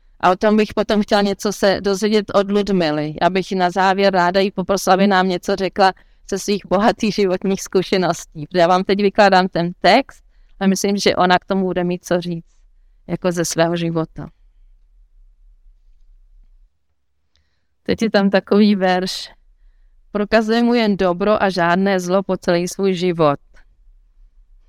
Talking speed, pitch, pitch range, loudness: 155 wpm, 180 Hz, 140-195 Hz, -17 LUFS